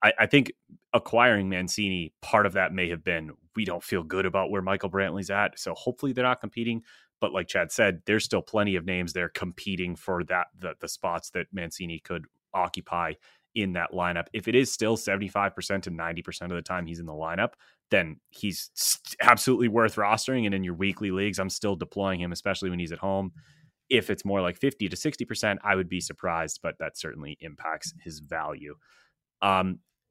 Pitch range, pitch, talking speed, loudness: 90-105 Hz, 95 Hz, 195 wpm, -28 LUFS